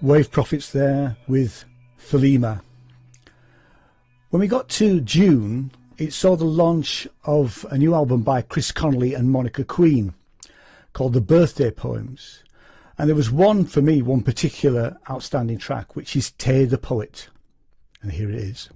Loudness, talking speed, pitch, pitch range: -20 LUFS, 150 wpm, 135 Hz, 125-155 Hz